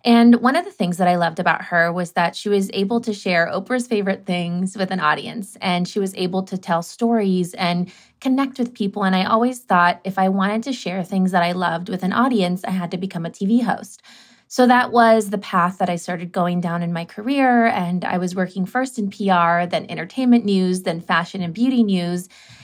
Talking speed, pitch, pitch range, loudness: 225 wpm, 190 Hz, 175-225 Hz, -19 LUFS